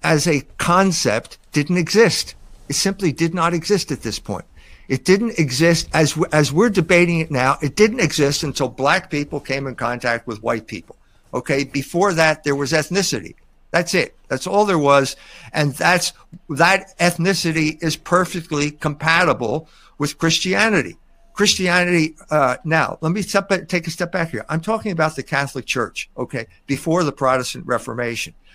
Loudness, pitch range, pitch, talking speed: -19 LUFS, 140-180 Hz, 160 Hz, 165 wpm